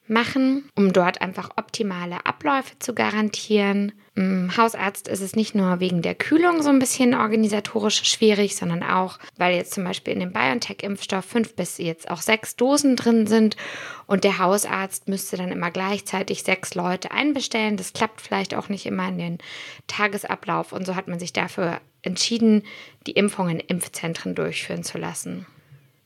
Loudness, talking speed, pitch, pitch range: -23 LUFS, 165 wpm, 200 Hz, 180-220 Hz